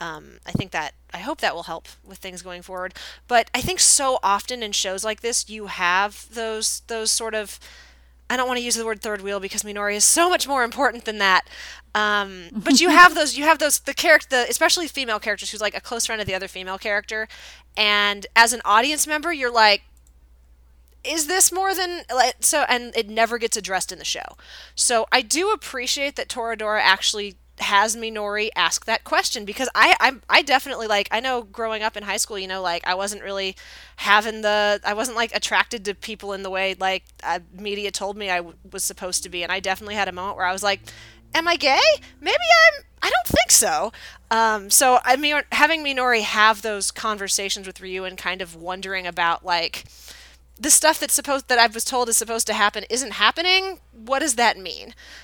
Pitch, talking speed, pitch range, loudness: 215 Hz, 215 wpm, 195-250 Hz, -20 LUFS